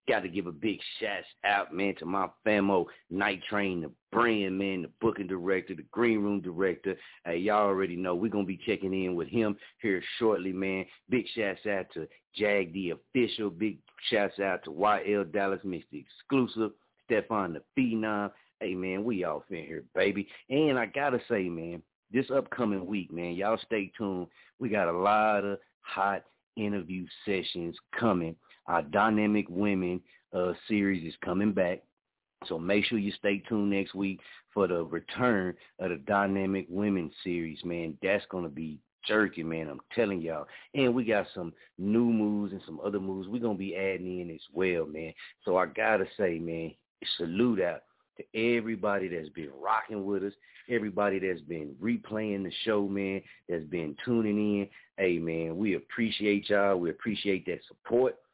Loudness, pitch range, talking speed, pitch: -31 LUFS, 90-105 Hz, 175 wpm, 100 Hz